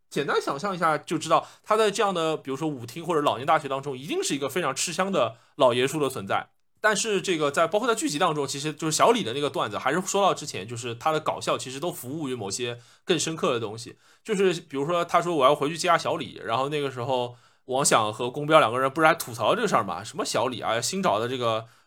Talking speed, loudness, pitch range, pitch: 385 characters per minute, -25 LUFS, 130-180 Hz, 155 Hz